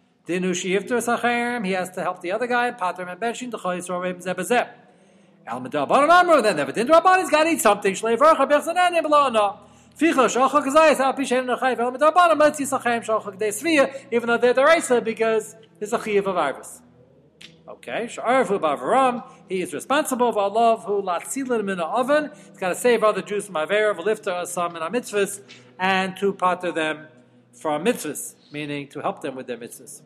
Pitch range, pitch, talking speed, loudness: 185-260 Hz, 225 Hz, 105 wpm, -21 LUFS